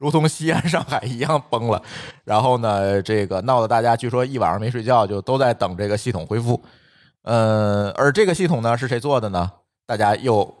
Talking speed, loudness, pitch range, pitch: 295 characters per minute, -20 LUFS, 105-130 Hz, 120 Hz